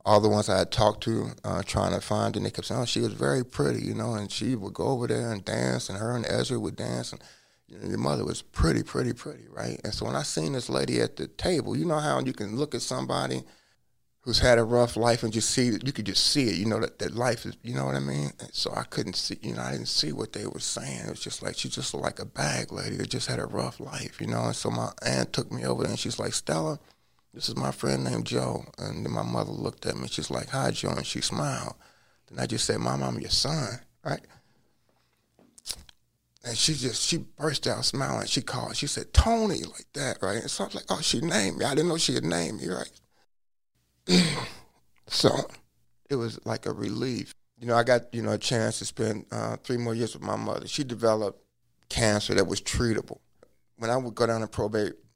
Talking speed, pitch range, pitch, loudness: 250 wpm, 90-120 Hz, 110 Hz, -28 LUFS